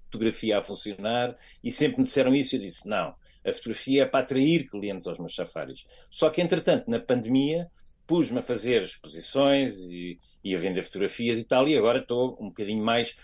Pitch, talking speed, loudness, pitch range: 125 Hz, 195 wpm, -26 LUFS, 110-135 Hz